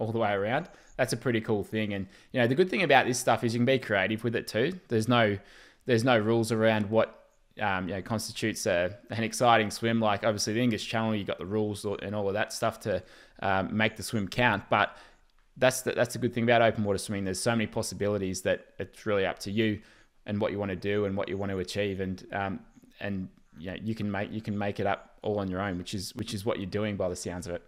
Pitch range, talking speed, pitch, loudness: 100-115 Hz, 265 wpm, 105 Hz, -29 LUFS